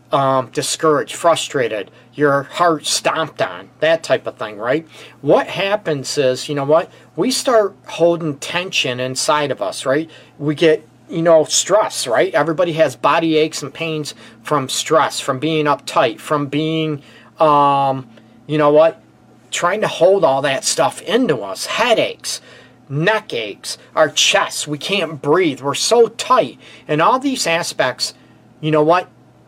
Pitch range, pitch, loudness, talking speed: 135-165 Hz, 155 Hz, -17 LUFS, 155 wpm